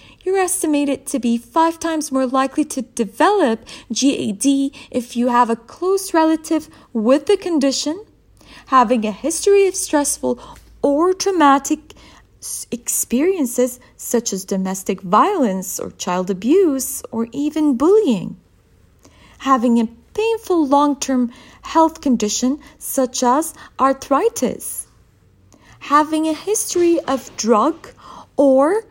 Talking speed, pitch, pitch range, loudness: 110 wpm, 280 Hz, 245-325 Hz, -18 LUFS